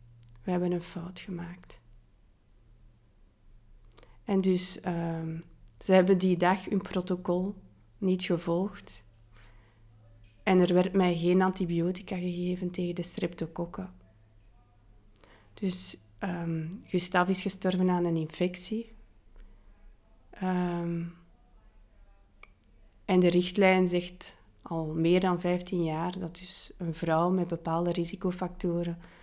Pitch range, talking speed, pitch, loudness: 110-185 Hz, 105 wpm, 175 Hz, -29 LUFS